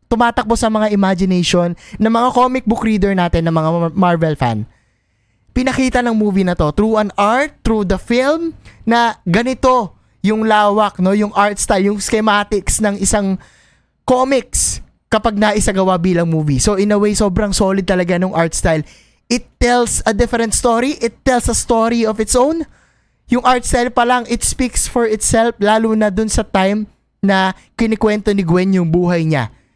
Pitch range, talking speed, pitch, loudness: 185-235 Hz, 175 wpm, 210 Hz, -15 LUFS